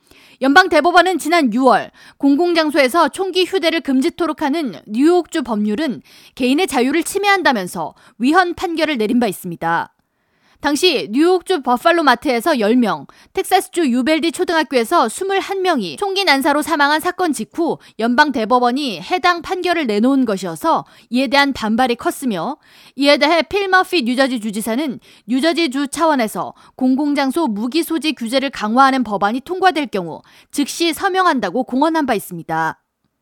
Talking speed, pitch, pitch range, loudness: 330 characters per minute, 290 Hz, 245-340 Hz, -16 LUFS